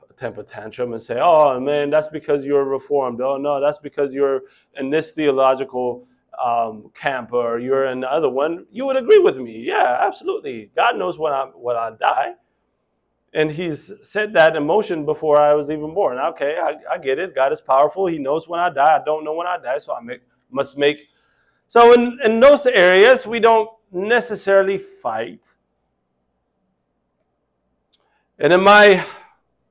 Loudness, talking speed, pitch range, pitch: -17 LUFS, 175 wpm, 135-195 Hz, 150 Hz